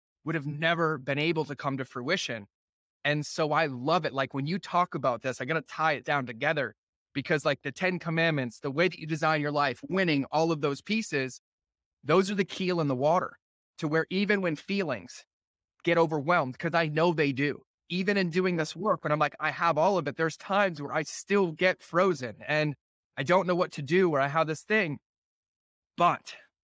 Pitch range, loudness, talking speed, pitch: 140-175 Hz, -28 LUFS, 215 wpm, 160 Hz